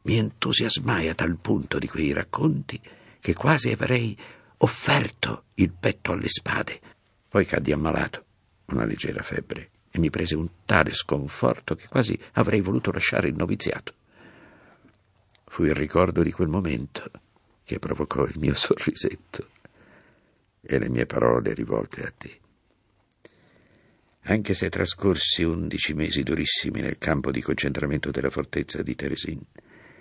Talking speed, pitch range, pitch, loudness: 135 wpm, 70-95 Hz, 80 Hz, -25 LUFS